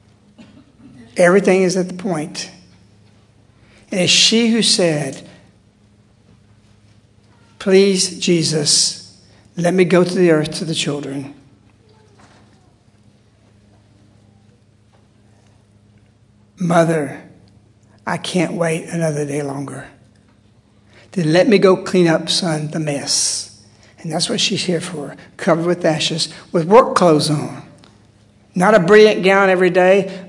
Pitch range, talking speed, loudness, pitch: 105-175 Hz, 110 wpm, -15 LUFS, 145 Hz